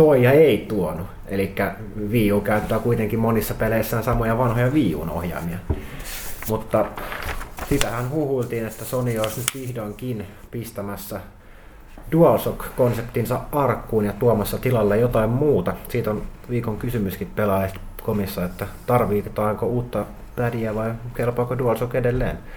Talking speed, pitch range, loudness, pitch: 115 wpm, 100-120 Hz, -23 LUFS, 110 Hz